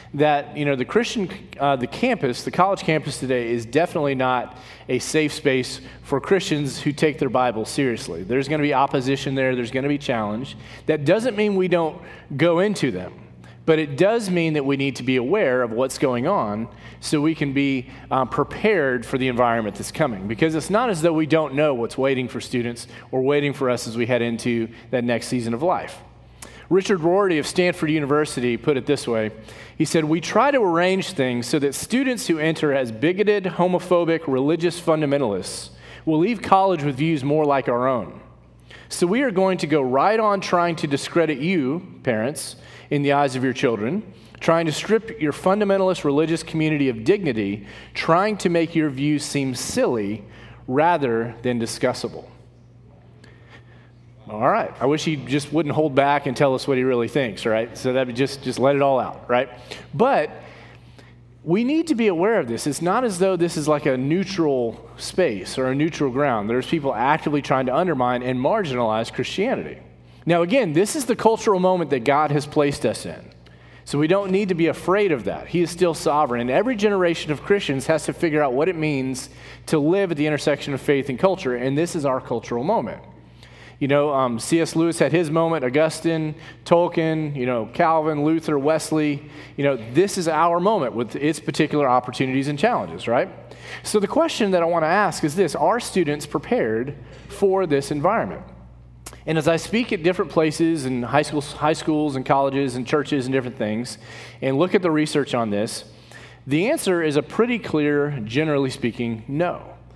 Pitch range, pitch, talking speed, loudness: 125-165 Hz, 145 Hz, 195 wpm, -21 LUFS